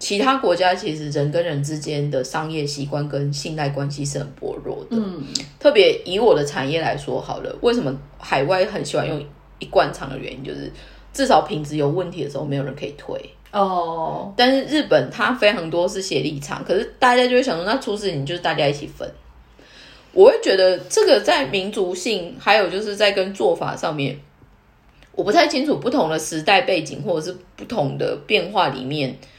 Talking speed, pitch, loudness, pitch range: 295 characters per minute, 175 Hz, -20 LUFS, 145-210 Hz